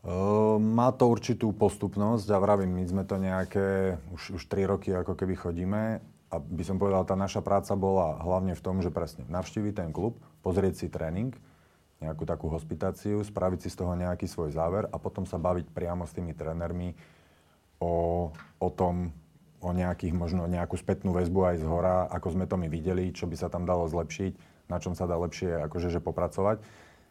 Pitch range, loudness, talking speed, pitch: 85-95 Hz, -30 LUFS, 195 wpm, 90 Hz